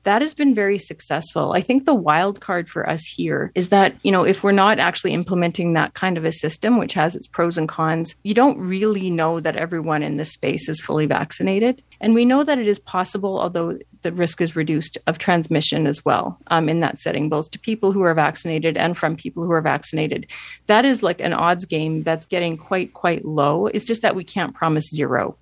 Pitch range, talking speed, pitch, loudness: 160-200 Hz, 225 wpm, 170 Hz, -20 LUFS